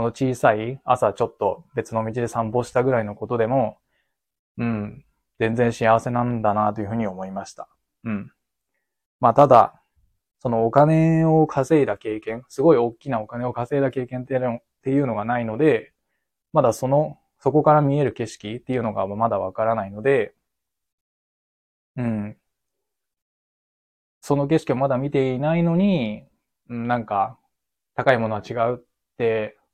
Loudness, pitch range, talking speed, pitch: -22 LUFS, 110-135 Hz, 300 characters per minute, 120 Hz